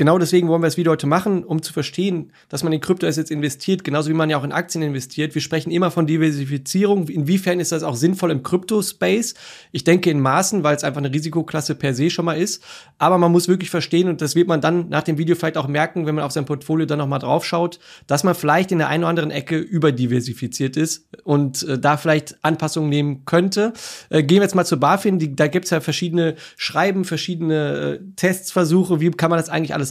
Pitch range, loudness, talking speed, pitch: 150-175 Hz, -19 LUFS, 230 wpm, 160 Hz